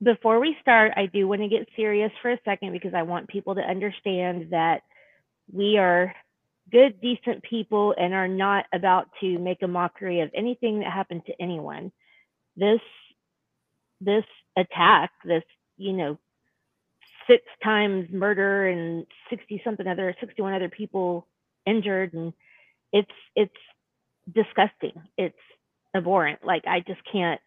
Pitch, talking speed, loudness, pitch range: 195 Hz, 140 wpm, -24 LUFS, 180-215 Hz